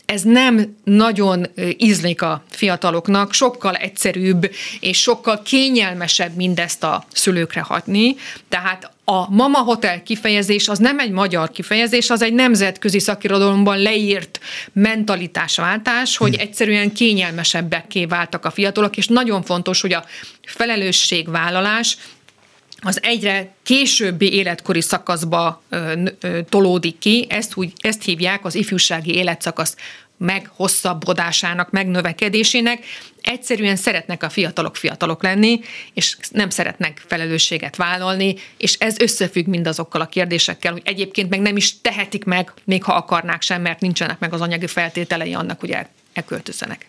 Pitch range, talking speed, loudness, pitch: 175-210 Hz, 125 wpm, -17 LUFS, 190 Hz